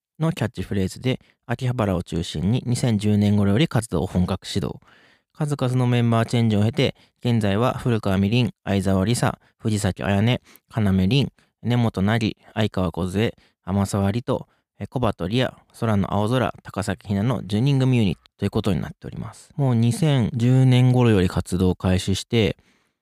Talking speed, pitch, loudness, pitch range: 305 characters per minute, 110 Hz, -22 LUFS, 95-125 Hz